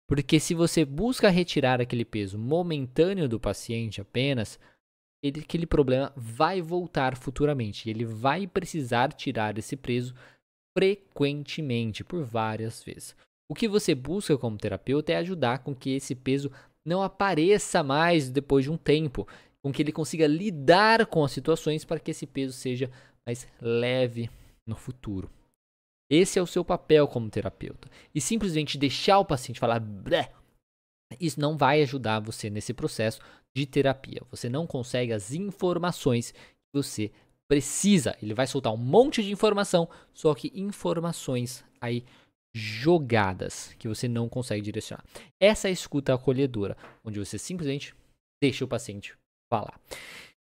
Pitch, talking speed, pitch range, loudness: 140 Hz, 145 wpm, 115-165 Hz, -27 LUFS